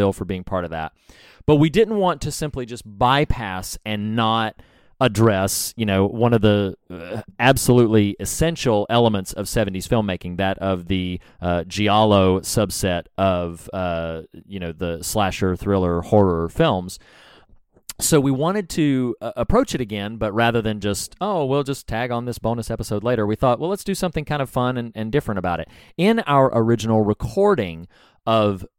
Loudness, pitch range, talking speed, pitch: -20 LUFS, 95-125 Hz, 170 wpm, 110 Hz